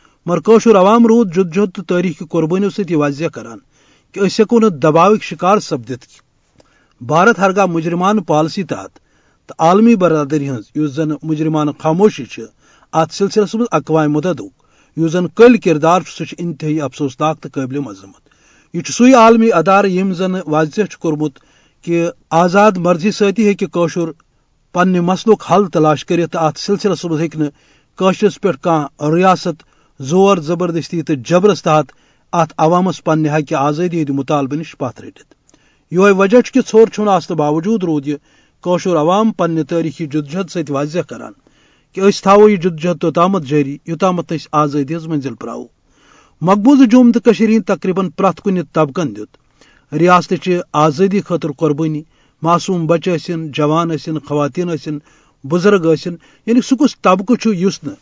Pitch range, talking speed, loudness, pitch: 155-195 Hz, 140 wpm, -14 LUFS, 170 Hz